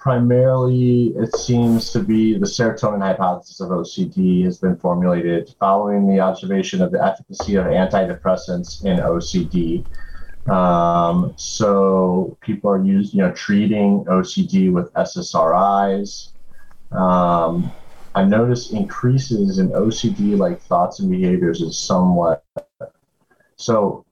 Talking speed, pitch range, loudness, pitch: 120 wpm, 95-140 Hz, -18 LUFS, 105 Hz